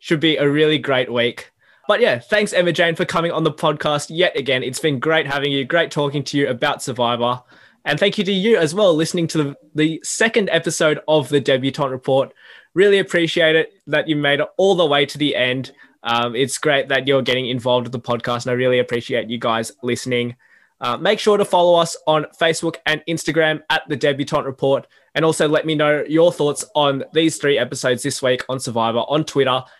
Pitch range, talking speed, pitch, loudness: 130-165 Hz, 215 wpm, 150 Hz, -18 LUFS